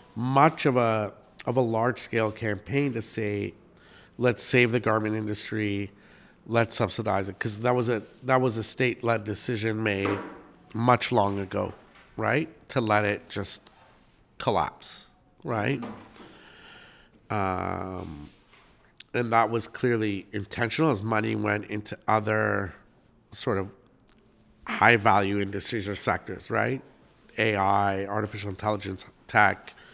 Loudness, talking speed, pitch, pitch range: -27 LUFS, 125 wpm, 110 Hz, 100-120 Hz